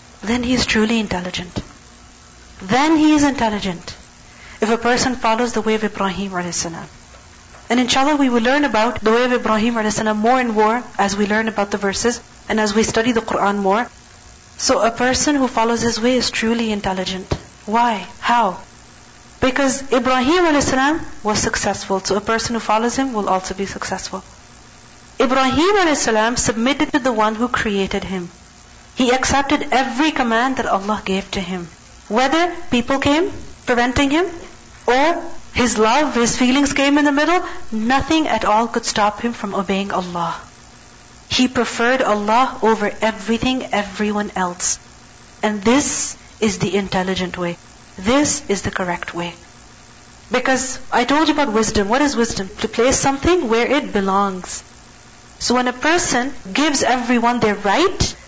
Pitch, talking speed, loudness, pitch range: 230 Hz, 160 wpm, -18 LUFS, 205-265 Hz